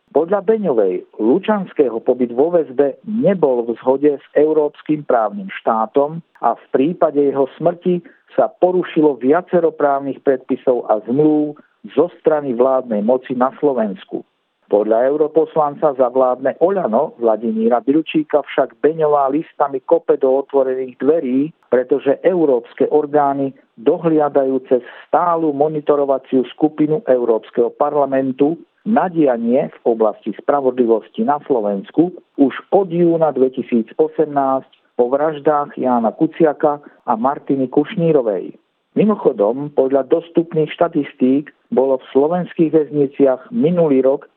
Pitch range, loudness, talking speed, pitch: 130-160 Hz, -17 LUFS, 110 wpm, 145 Hz